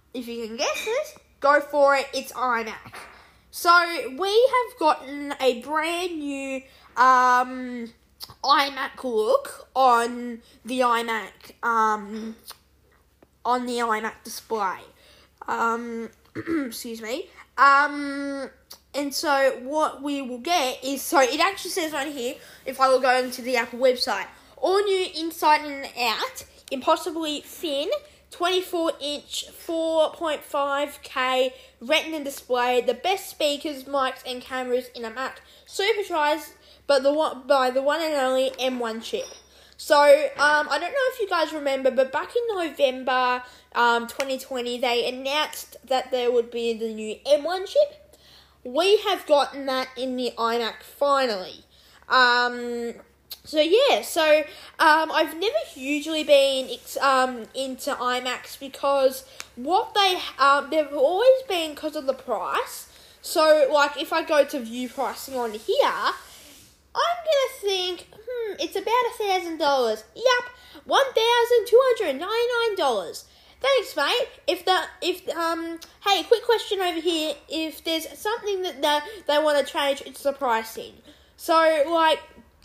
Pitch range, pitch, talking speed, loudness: 255-345 Hz, 285 Hz, 140 wpm, -23 LUFS